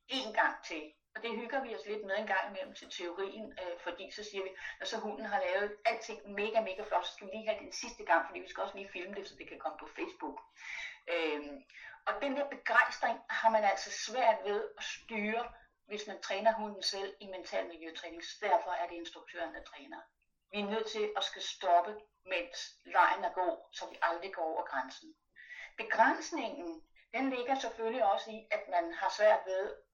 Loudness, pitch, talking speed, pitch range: -35 LUFS, 215 Hz, 210 wpm, 195-270 Hz